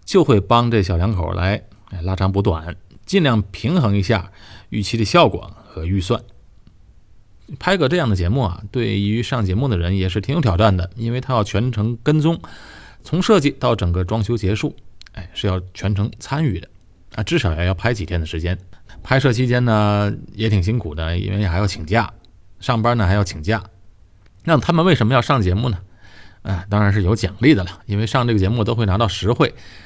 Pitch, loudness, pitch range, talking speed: 105 Hz, -19 LUFS, 95-120 Hz, 285 characters per minute